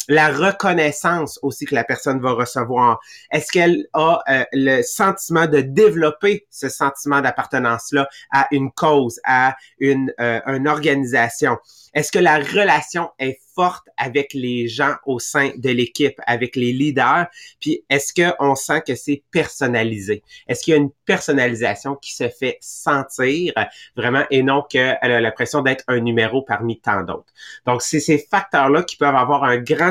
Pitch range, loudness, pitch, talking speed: 130-155 Hz, -18 LUFS, 140 Hz, 165 wpm